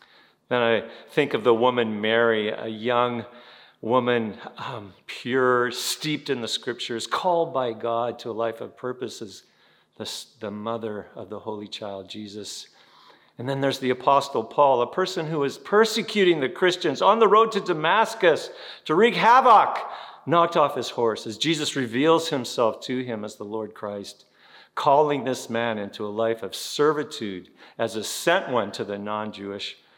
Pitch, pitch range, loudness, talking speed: 125 Hz, 110-150 Hz, -23 LUFS, 165 wpm